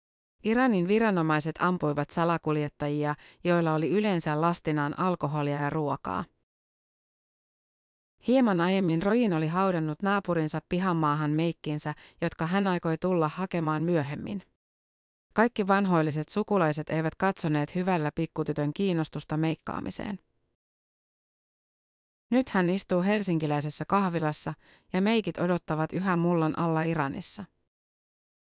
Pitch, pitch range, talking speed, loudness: 165 Hz, 150-185 Hz, 95 wpm, -28 LUFS